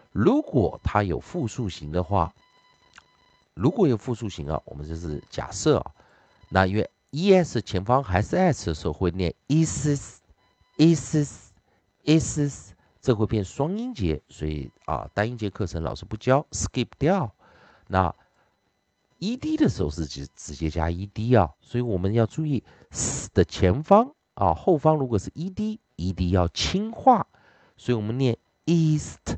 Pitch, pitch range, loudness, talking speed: 105 Hz, 90-145 Hz, -25 LUFS, 235 characters per minute